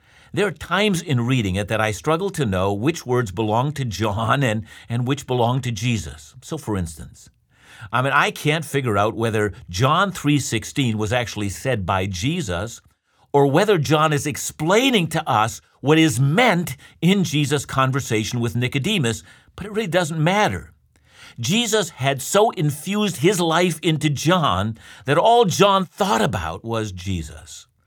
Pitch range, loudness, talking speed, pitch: 110-165 Hz, -20 LUFS, 160 wpm, 135 Hz